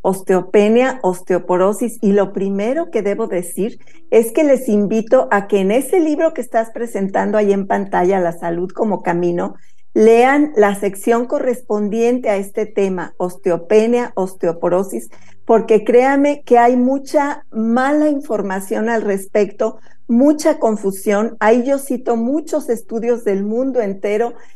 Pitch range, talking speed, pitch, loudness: 195-245 Hz, 135 wpm, 220 Hz, -16 LUFS